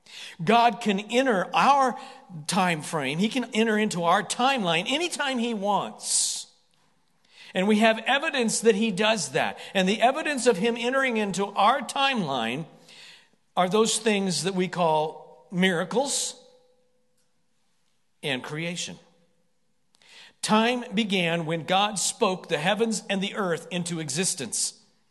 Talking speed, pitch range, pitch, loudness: 125 wpm, 175-240 Hz, 210 Hz, -25 LUFS